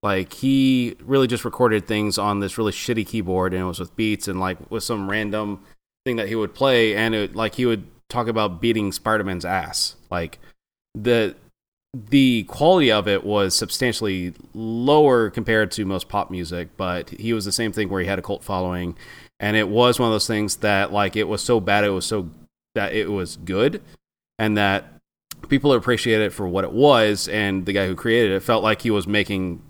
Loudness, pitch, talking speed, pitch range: -21 LUFS, 105 Hz, 205 wpm, 95-115 Hz